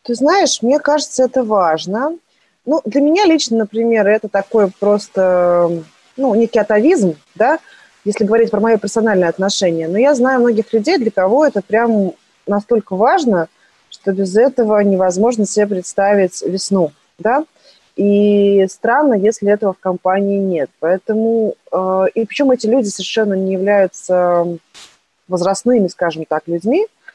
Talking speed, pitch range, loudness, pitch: 135 wpm, 190-235 Hz, -15 LUFS, 210 Hz